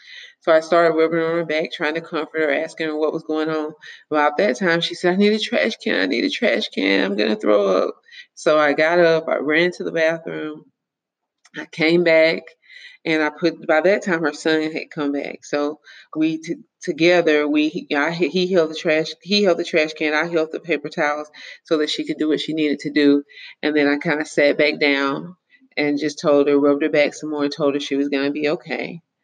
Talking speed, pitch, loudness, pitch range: 235 wpm, 155 Hz, -19 LUFS, 150-170 Hz